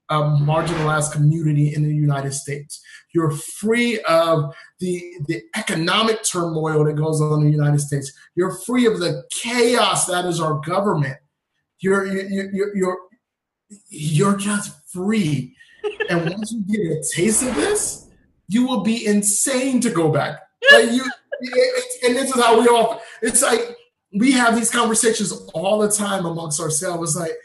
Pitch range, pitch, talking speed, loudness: 160-230 Hz, 190 Hz, 165 wpm, -19 LUFS